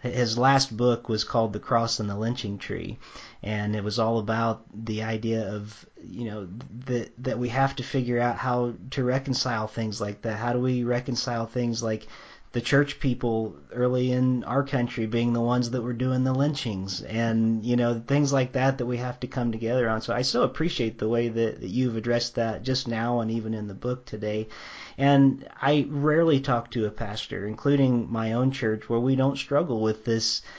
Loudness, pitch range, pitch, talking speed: -26 LUFS, 110-130 Hz, 120 Hz, 200 wpm